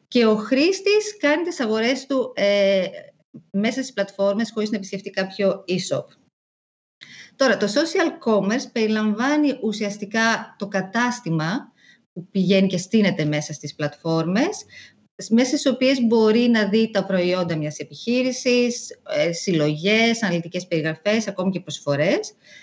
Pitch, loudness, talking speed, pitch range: 210 Hz, -21 LUFS, 125 wpm, 180-245 Hz